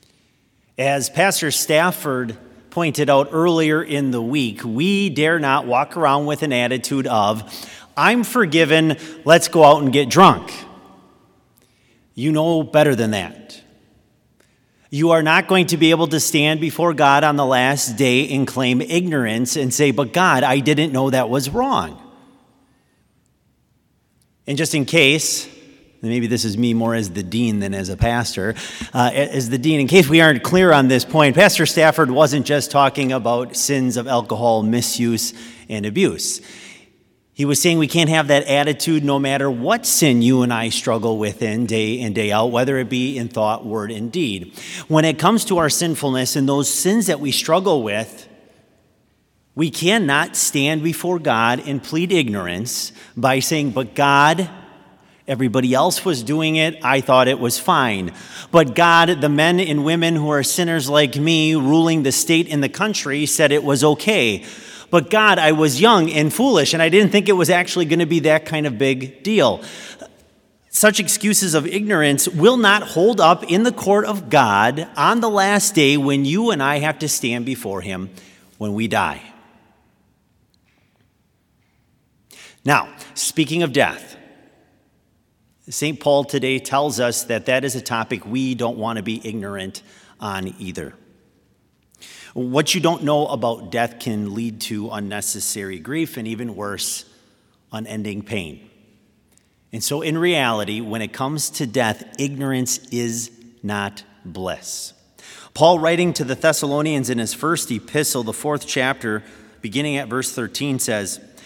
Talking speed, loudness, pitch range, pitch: 165 wpm, -17 LUFS, 120-160 Hz, 140 Hz